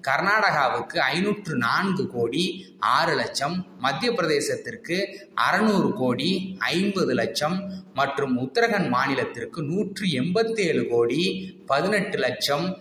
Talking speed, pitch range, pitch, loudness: 95 wpm, 140-205 Hz, 185 Hz, -24 LUFS